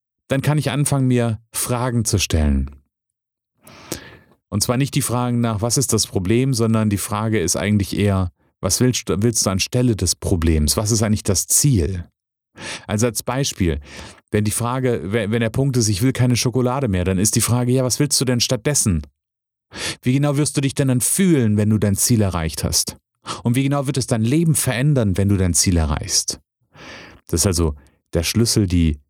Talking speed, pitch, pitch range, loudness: 195 wpm, 115 Hz, 95-125 Hz, -19 LUFS